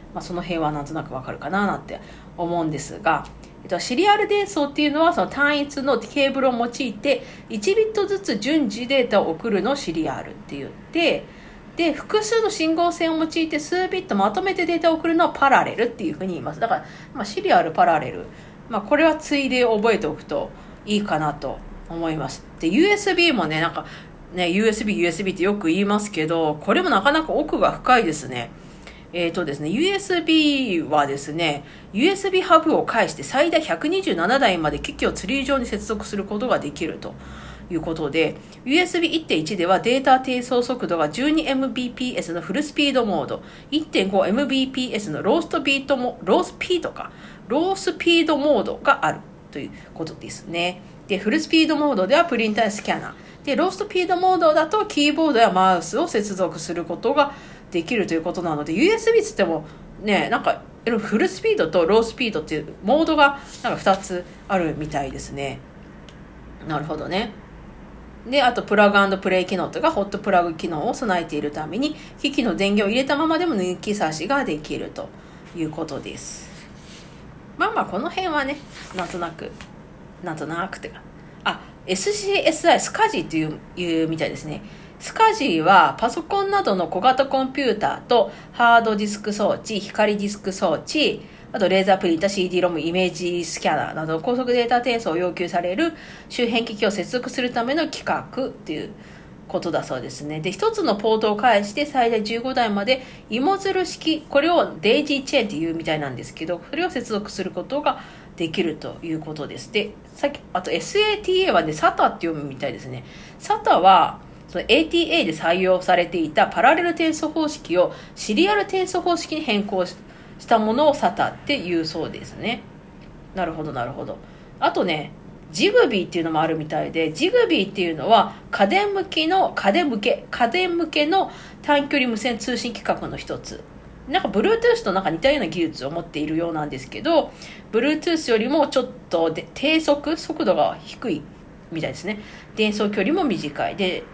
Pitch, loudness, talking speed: 225 Hz, -21 LUFS, 375 characters per minute